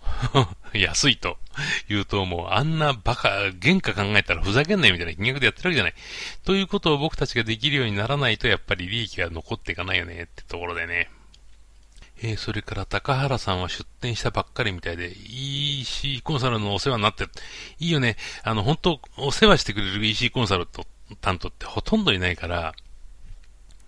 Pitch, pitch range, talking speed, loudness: 110 Hz, 95-135 Hz, 400 characters per minute, -23 LUFS